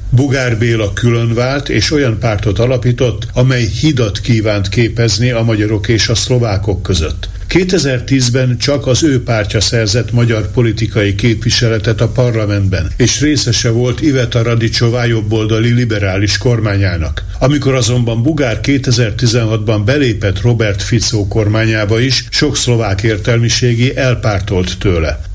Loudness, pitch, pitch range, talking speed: -12 LUFS, 115 Hz, 105-125 Hz, 120 wpm